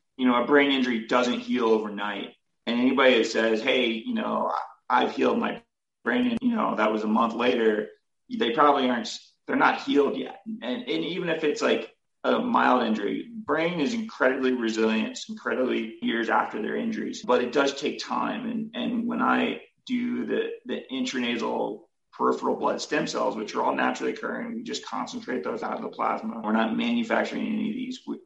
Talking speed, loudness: 190 wpm, -26 LUFS